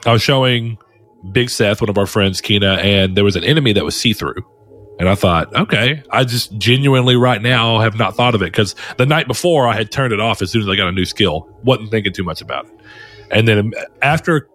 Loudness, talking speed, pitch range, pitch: -15 LUFS, 245 wpm, 100-125 Hz, 110 Hz